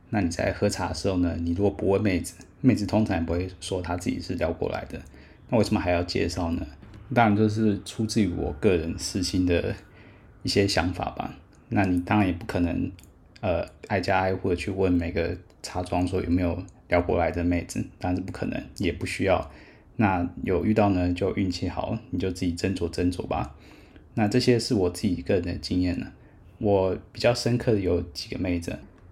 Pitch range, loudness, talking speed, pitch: 90-105 Hz, -26 LUFS, 290 characters per minute, 95 Hz